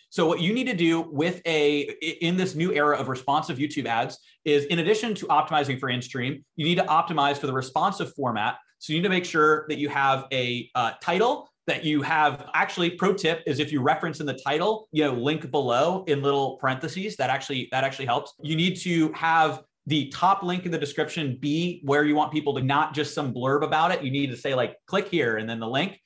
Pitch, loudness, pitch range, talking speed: 150 Hz, -25 LUFS, 140-165 Hz, 235 wpm